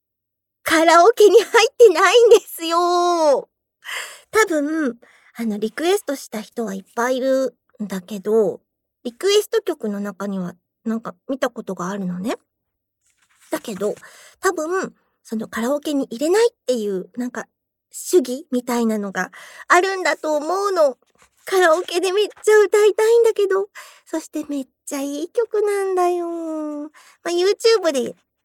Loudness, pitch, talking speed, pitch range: -19 LUFS, 305 Hz, 295 characters per minute, 230-380 Hz